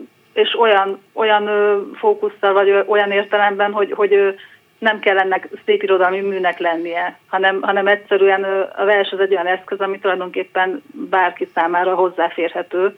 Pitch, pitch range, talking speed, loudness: 195 Hz, 185-205 Hz, 135 wpm, -17 LUFS